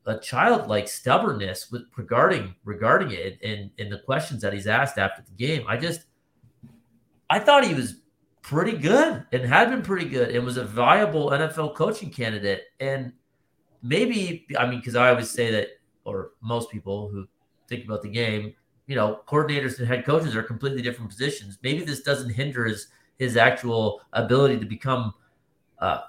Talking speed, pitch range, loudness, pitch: 175 wpm, 110-145 Hz, -24 LUFS, 125 Hz